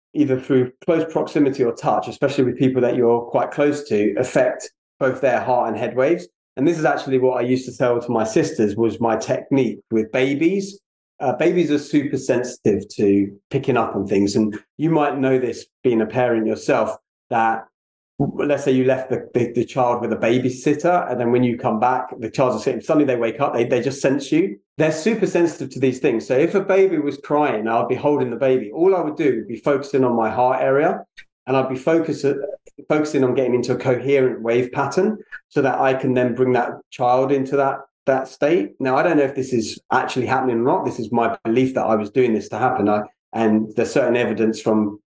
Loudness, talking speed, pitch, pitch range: -20 LUFS, 225 wpm, 130 Hz, 120-145 Hz